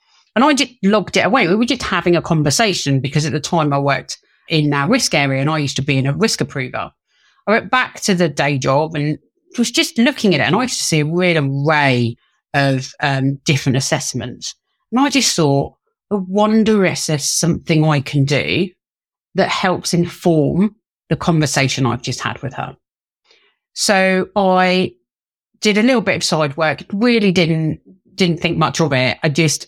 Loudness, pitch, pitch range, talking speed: -16 LUFS, 160 Hz, 140-200 Hz, 195 wpm